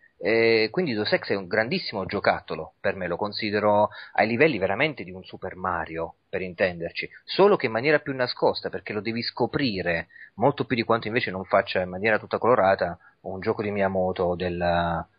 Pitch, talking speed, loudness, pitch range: 105 Hz, 180 wpm, -25 LUFS, 95-115 Hz